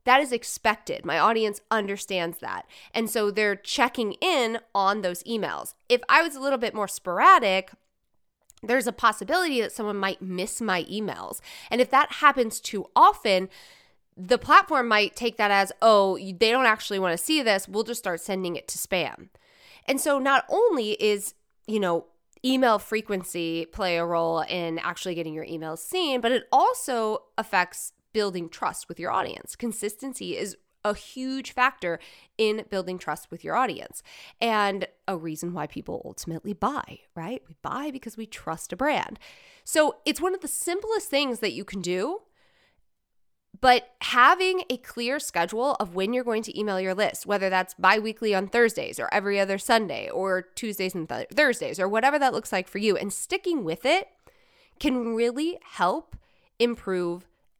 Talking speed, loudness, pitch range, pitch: 175 wpm, -25 LUFS, 185-255 Hz, 215 Hz